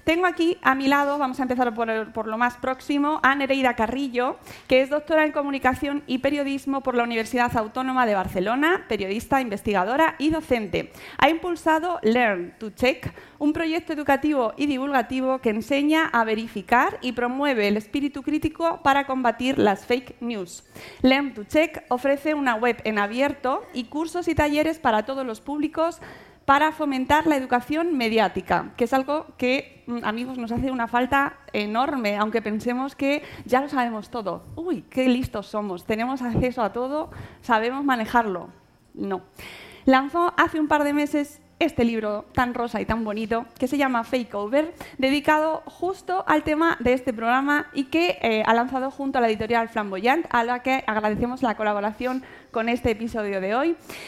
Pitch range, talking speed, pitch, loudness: 235-290 Hz, 170 wpm, 260 Hz, -23 LUFS